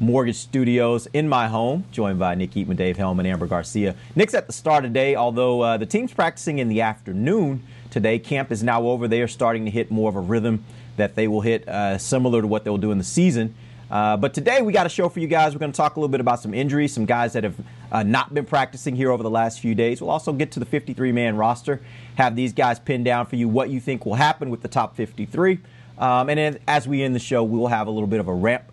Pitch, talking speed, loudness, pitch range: 120 Hz, 265 wpm, -22 LUFS, 110-135 Hz